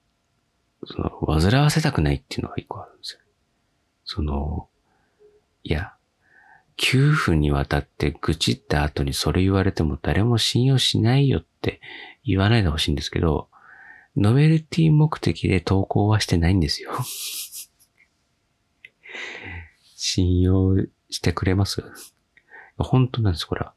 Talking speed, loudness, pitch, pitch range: 265 characters per minute, -22 LUFS, 95 Hz, 80-120 Hz